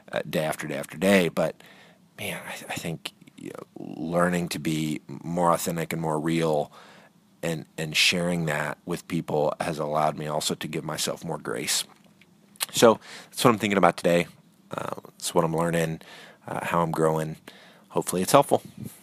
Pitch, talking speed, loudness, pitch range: 80 Hz, 175 wpm, -26 LUFS, 80-85 Hz